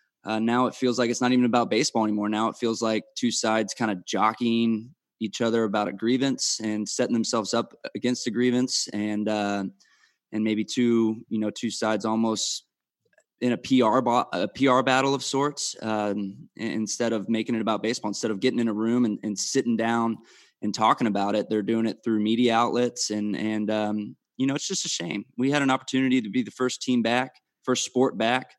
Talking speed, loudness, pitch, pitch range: 210 wpm, -25 LUFS, 115 Hz, 110-125 Hz